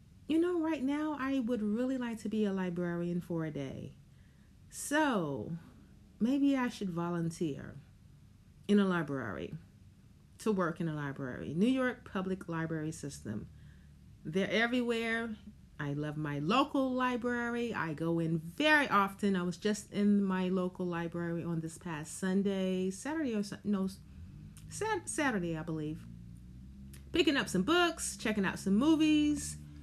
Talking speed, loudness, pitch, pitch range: 140 wpm, -33 LUFS, 190 Hz, 160-240 Hz